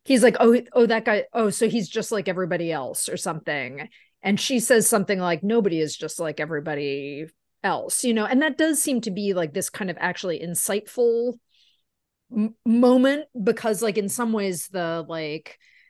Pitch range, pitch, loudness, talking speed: 170-235 Hz, 215 Hz, -23 LUFS, 185 wpm